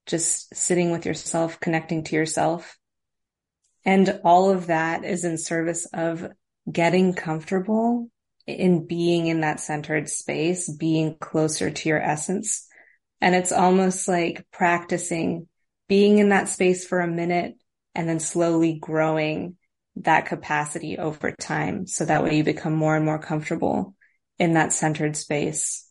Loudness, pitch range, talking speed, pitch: -23 LUFS, 155-180 Hz, 140 wpm, 170 Hz